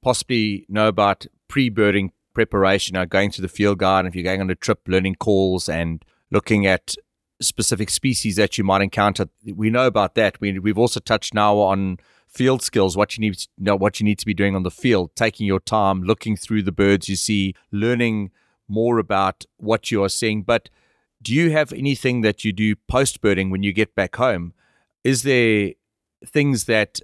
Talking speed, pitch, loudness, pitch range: 195 wpm, 105 Hz, -20 LUFS, 95-115 Hz